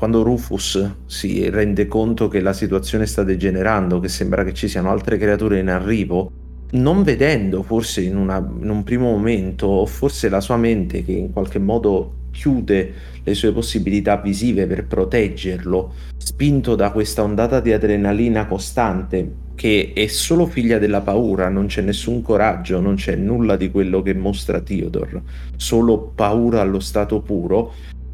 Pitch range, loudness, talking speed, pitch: 95-110 Hz, -19 LUFS, 160 wpm, 100 Hz